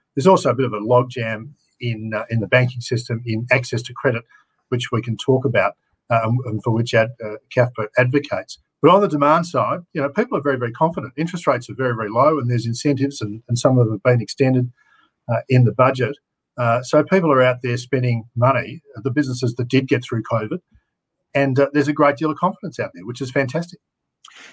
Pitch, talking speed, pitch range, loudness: 125 Hz, 225 wpm, 115-140 Hz, -19 LUFS